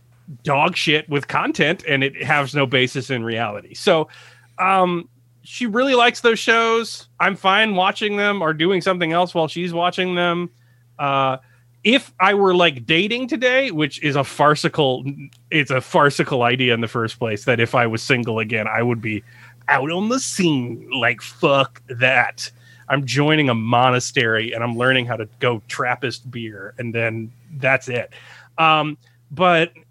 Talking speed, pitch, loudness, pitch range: 165 wpm, 135 Hz, -18 LUFS, 120-170 Hz